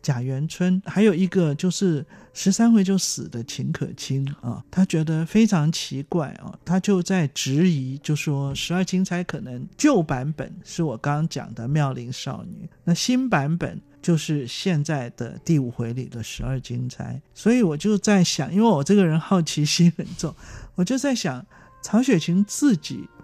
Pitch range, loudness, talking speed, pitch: 140-185 Hz, -23 LUFS, 250 characters per minute, 165 Hz